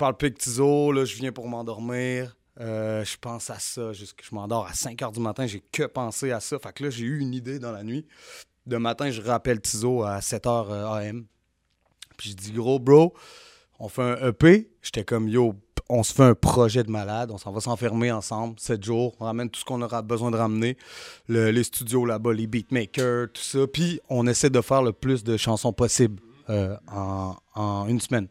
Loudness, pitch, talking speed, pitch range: -25 LUFS, 120 Hz, 220 wpm, 110-125 Hz